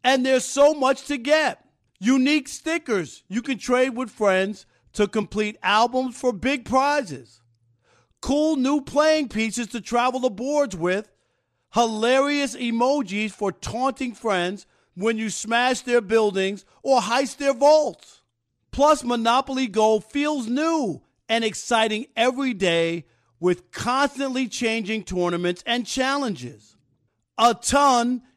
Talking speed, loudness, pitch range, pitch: 125 wpm, -22 LUFS, 200-270 Hz, 240 Hz